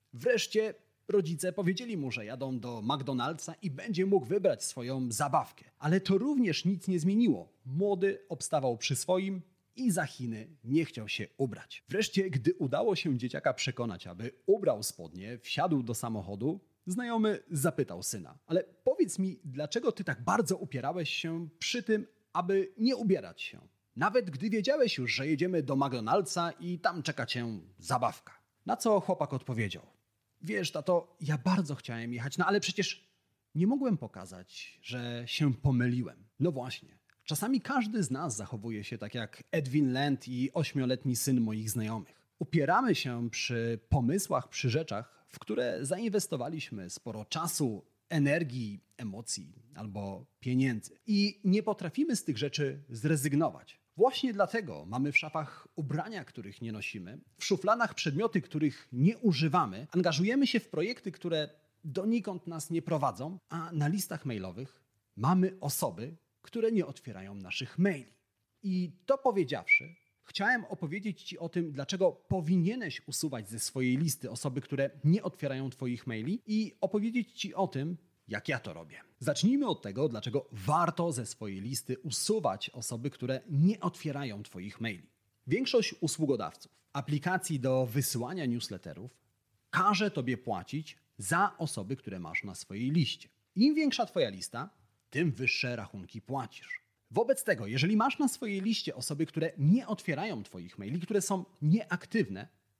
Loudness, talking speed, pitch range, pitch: -32 LUFS, 145 wpm, 125-190 Hz, 150 Hz